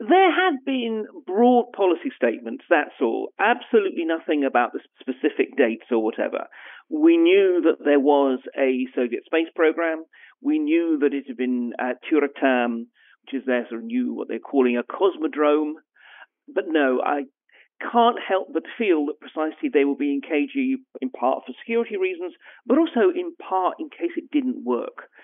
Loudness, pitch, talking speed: -22 LUFS, 165 Hz, 170 wpm